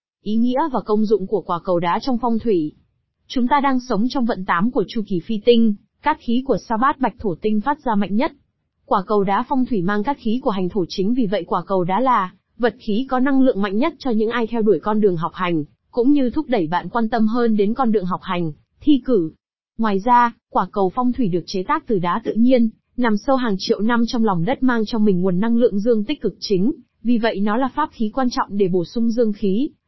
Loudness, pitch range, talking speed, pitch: -20 LUFS, 200-245 Hz, 260 wpm, 225 Hz